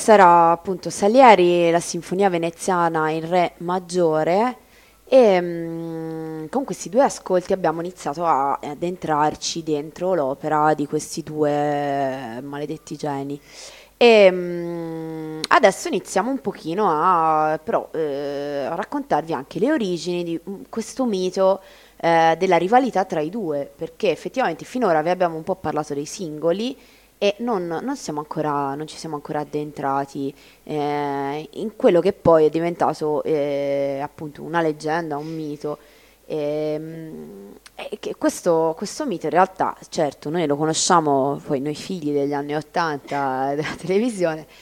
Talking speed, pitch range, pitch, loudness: 140 wpm, 150-185 Hz, 160 Hz, -21 LUFS